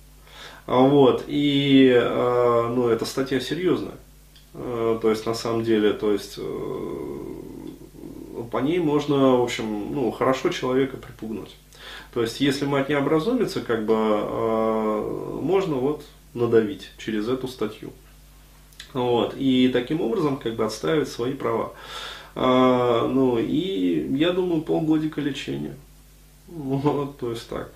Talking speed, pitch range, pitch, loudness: 130 wpm, 115-145 Hz, 130 Hz, -23 LUFS